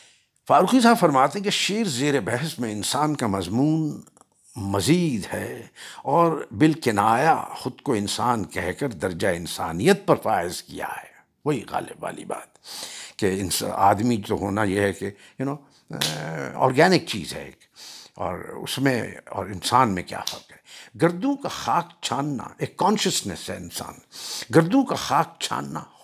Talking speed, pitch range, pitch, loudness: 155 wpm, 100-165 Hz, 135 Hz, -23 LUFS